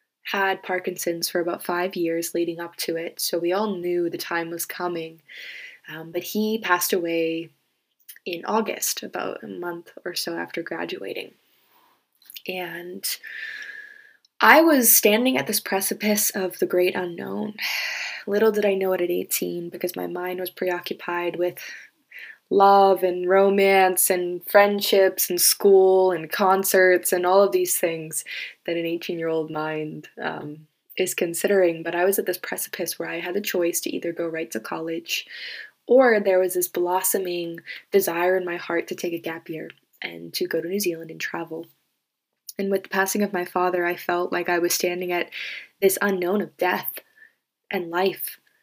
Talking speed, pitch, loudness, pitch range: 170 wpm, 180 Hz, -23 LUFS, 170-195 Hz